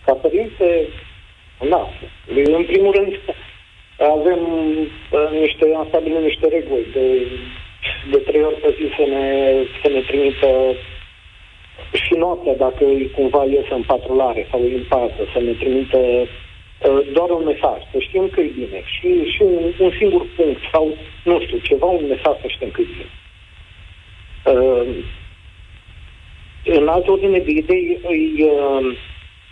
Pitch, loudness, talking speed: 140 Hz, -17 LUFS, 145 wpm